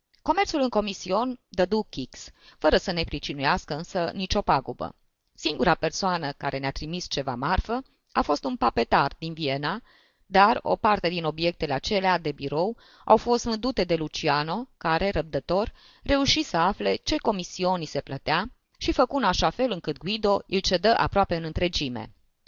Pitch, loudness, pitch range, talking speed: 180 Hz, -26 LUFS, 155-210 Hz, 155 wpm